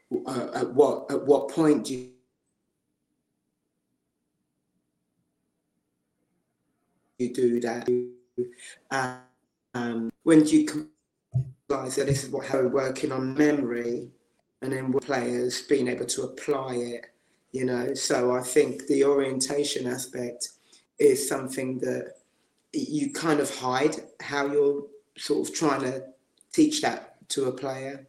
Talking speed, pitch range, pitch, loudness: 130 wpm, 120-140 Hz, 130 Hz, -27 LUFS